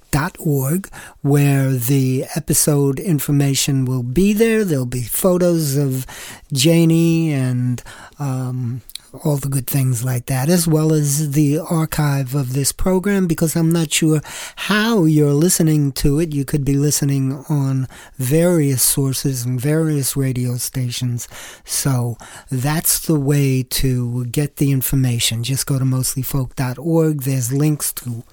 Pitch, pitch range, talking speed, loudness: 140 Hz, 130-155 Hz, 140 wpm, -18 LUFS